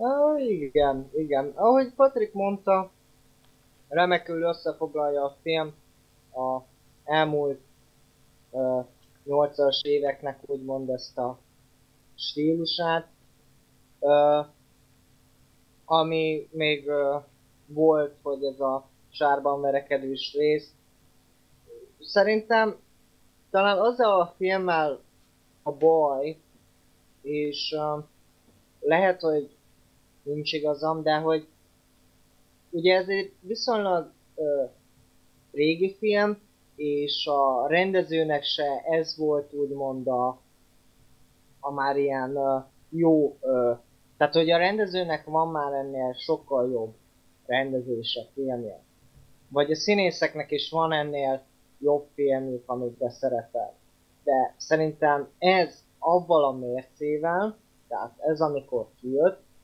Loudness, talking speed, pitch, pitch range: -26 LUFS, 95 wpm, 145 Hz, 135-160 Hz